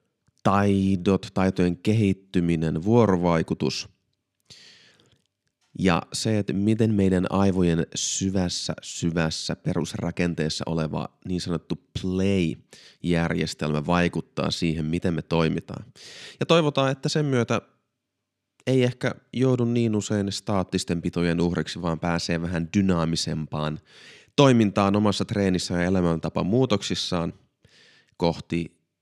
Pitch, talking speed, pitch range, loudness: 90 Hz, 95 wpm, 85-105 Hz, -24 LUFS